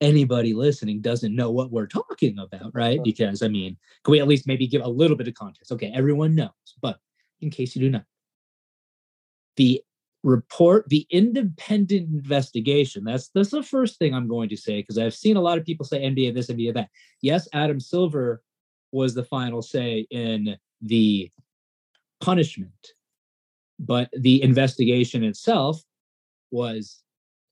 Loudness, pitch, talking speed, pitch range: -23 LUFS, 130 Hz, 160 wpm, 115-150 Hz